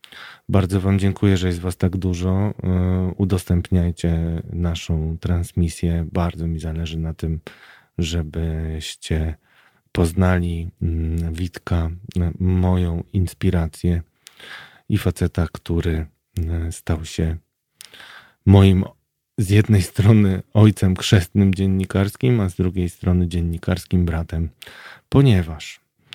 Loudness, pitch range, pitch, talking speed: -21 LUFS, 85-95 Hz, 90 Hz, 90 wpm